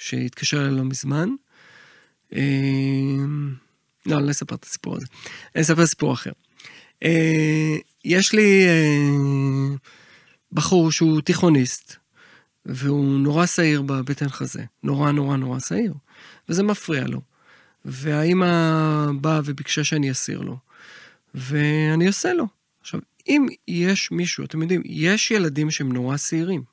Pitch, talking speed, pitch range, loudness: 150 Hz, 120 wpm, 140-170 Hz, -21 LUFS